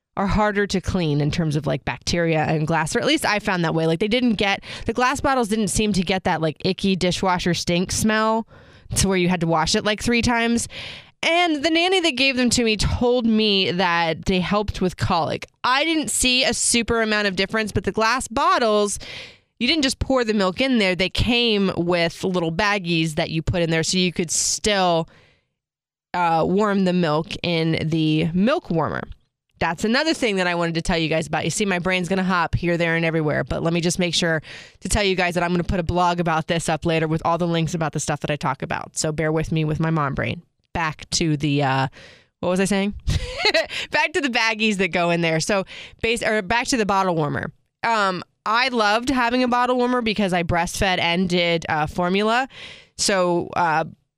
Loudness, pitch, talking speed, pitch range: -21 LUFS, 185 Hz, 225 wpm, 165-220 Hz